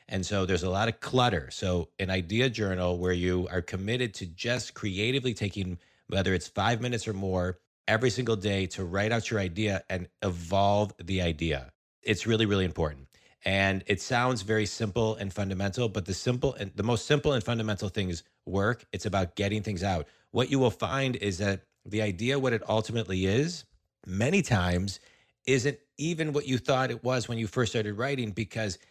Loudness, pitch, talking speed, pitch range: -29 LUFS, 105 Hz, 190 wpm, 95-120 Hz